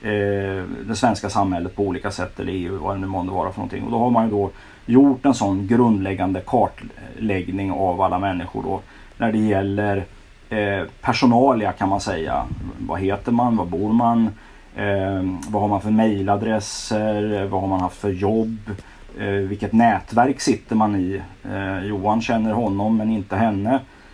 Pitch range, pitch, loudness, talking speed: 95-110 Hz, 100 Hz, -21 LUFS, 160 wpm